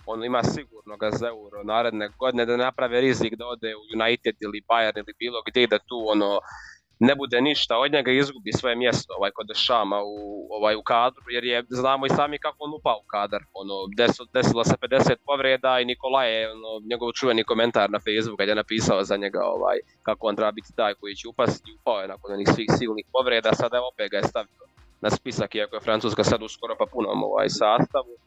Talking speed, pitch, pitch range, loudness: 215 wpm, 115 Hz, 105-125 Hz, -24 LUFS